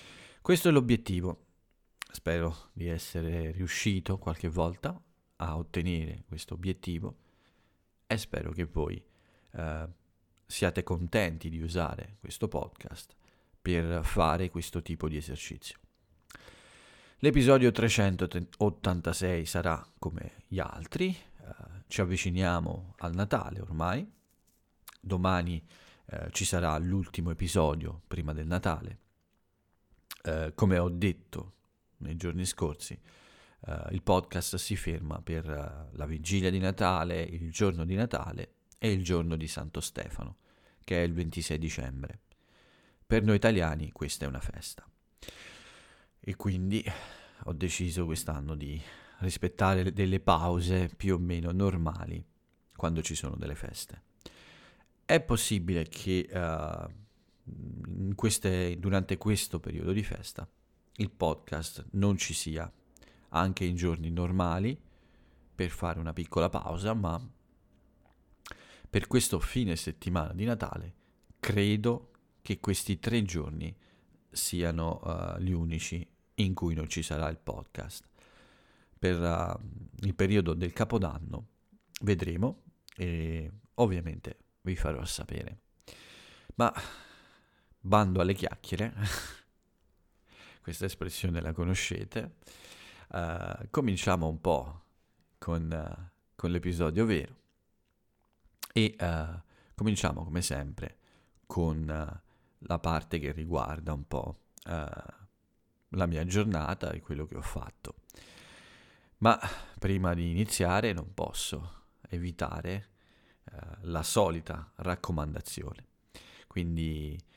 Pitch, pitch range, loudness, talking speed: 90 Hz, 80-100 Hz, -32 LUFS, 110 wpm